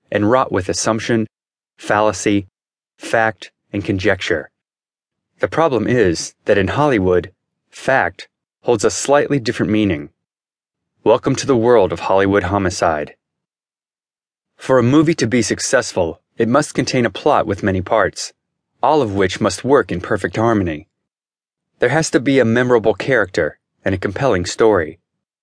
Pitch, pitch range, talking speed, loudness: 110 Hz, 100-125 Hz, 140 wpm, -17 LUFS